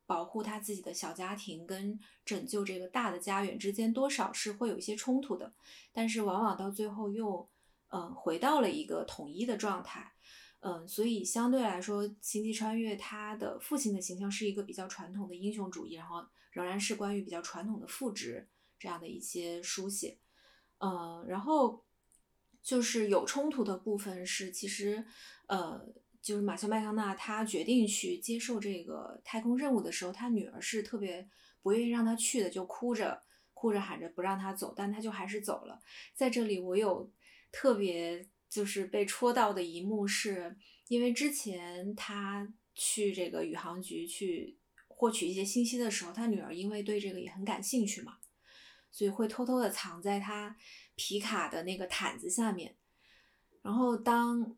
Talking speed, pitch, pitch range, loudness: 270 characters per minute, 210 Hz, 195-230 Hz, -35 LUFS